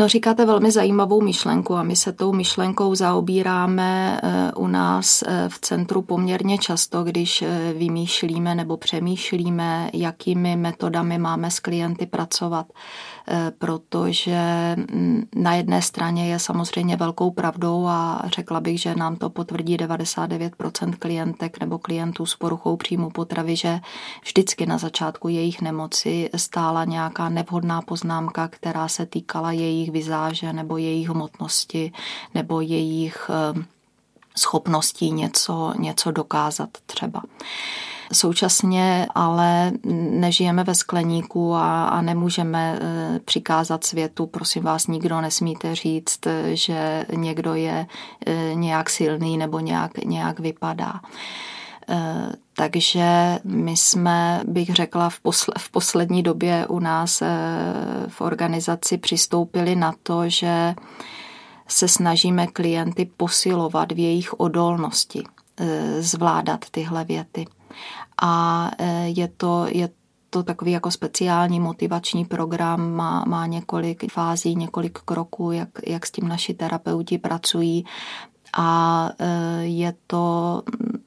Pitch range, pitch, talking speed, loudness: 165-175 Hz, 170 Hz, 110 wpm, -22 LUFS